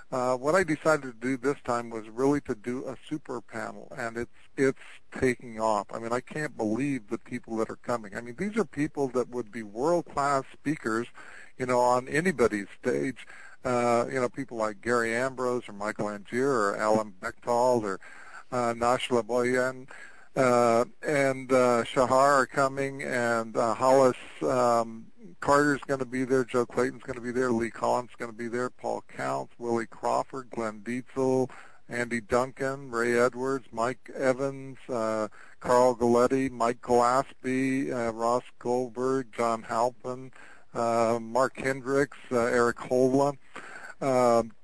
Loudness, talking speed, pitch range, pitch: -28 LUFS, 160 wpm, 115-135 Hz, 125 Hz